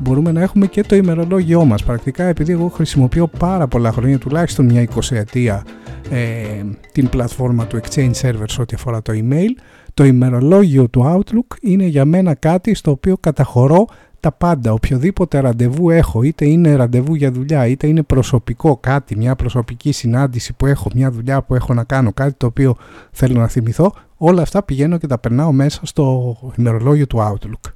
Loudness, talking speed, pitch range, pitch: -15 LUFS, 175 wpm, 120-160 Hz, 135 Hz